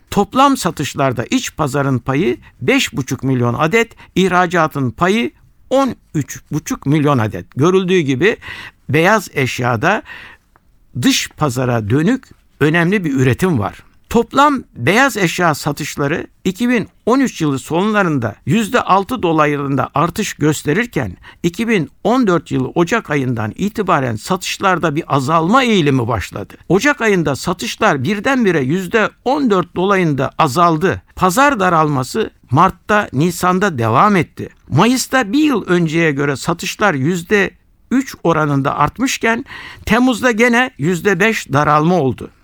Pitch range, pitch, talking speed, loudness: 145-220 Hz, 175 Hz, 100 wpm, -15 LUFS